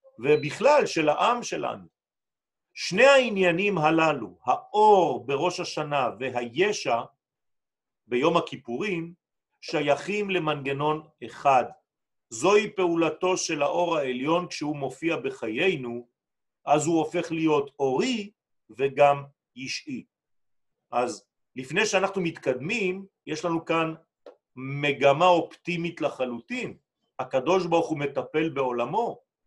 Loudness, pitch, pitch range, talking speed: -25 LUFS, 165 Hz, 145-185 Hz, 95 wpm